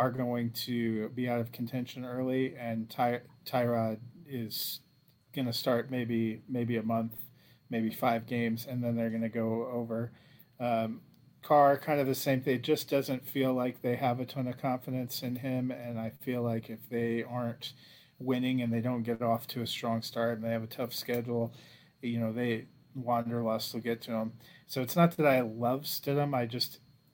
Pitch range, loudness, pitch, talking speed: 115-130 Hz, -33 LUFS, 120 Hz, 200 wpm